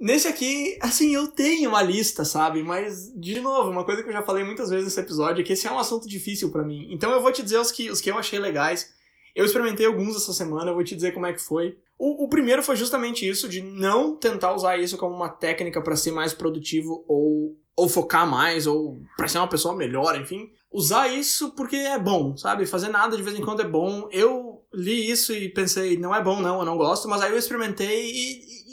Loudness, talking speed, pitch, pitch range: -24 LUFS, 240 wpm, 195 Hz, 175-235 Hz